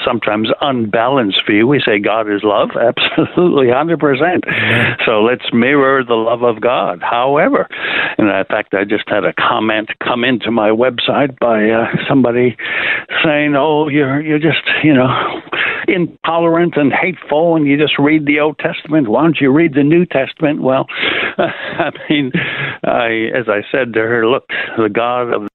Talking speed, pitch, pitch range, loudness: 165 wpm, 135 Hz, 115-155 Hz, -13 LUFS